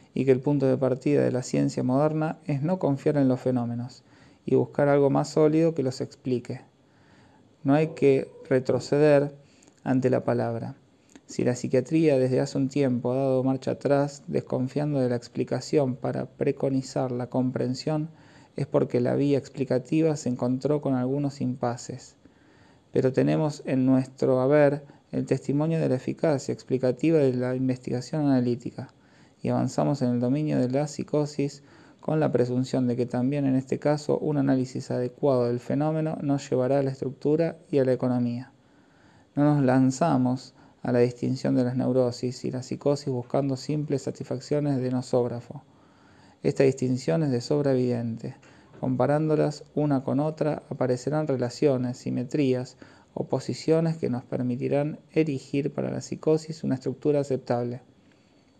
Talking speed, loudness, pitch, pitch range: 150 wpm, -26 LUFS, 135 Hz, 125-145 Hz